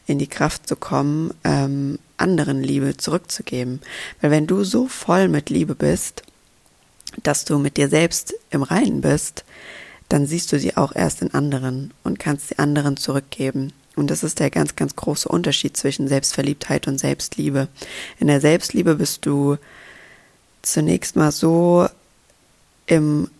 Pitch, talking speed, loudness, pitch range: 145 Hz, 150 wpm, -20 LUFS, 140-165 Hz